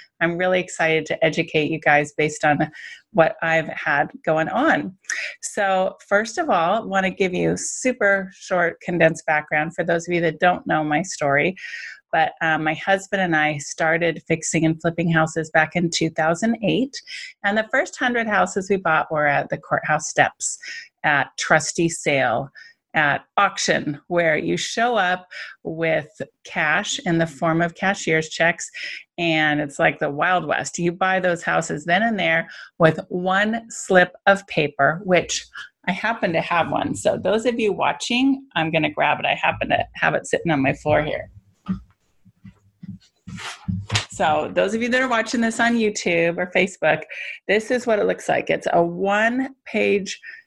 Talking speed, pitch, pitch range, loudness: 170 wpm, 175 Hz, 160-205 Hz, -21 LUFS